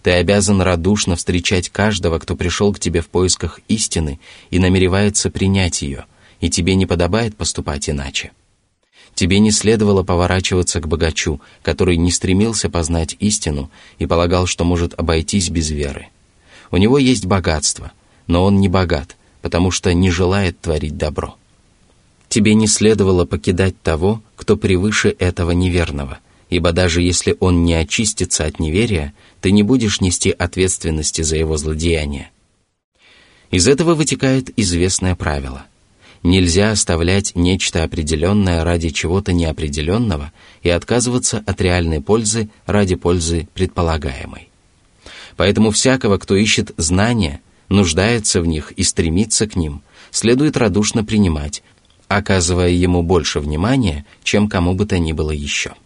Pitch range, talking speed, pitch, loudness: 85-100 Hz, 135 wpm, 90 Hz, -16 LUFS